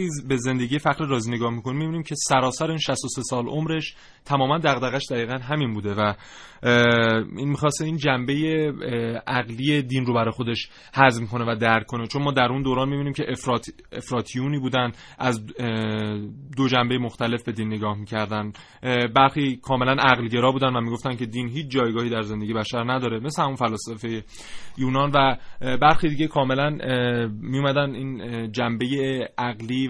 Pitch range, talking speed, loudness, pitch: 115-140 Hz, 155 wpm, -23 LUFS, 125 Hz